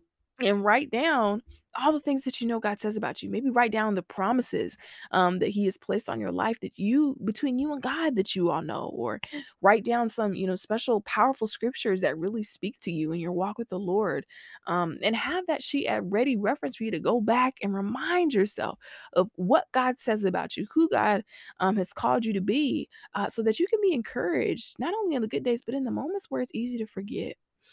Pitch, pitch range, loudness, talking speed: 225 Hz, 195-260 Hz, -27 LUFS, 235 wpm